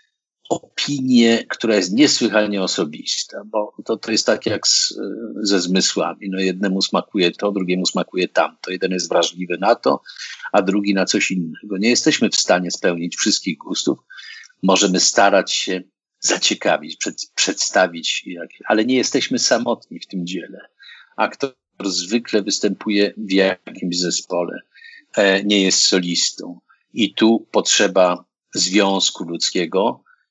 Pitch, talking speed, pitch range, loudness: 95 Hz, 130 wpm, 90-105 Hz, -18 LUFS